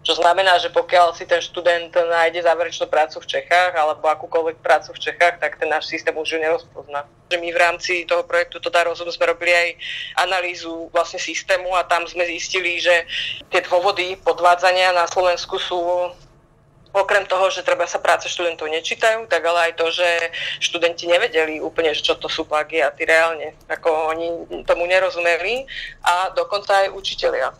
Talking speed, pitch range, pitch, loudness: 175 wpm, 165-180 Hz, 170 Hz, -19 LUFS